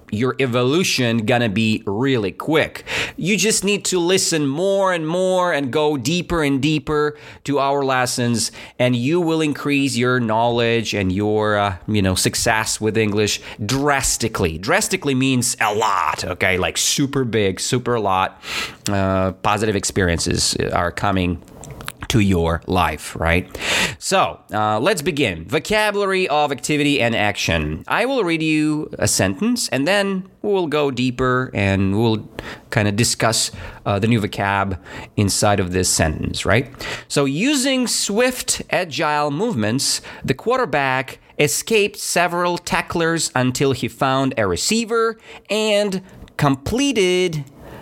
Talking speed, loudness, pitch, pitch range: 135 wpm, -19 LUFS, 130 Hz, 105-165 Hz